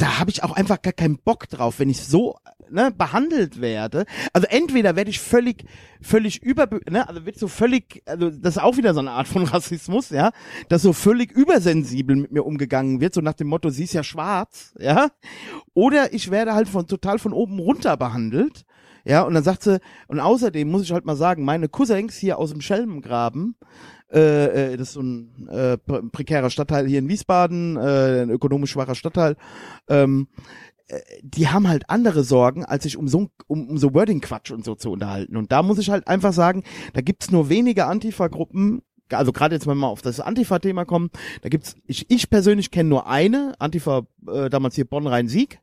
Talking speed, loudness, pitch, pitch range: 190 wpm, -20 LUFS, 170 Hz, 140-210 Hz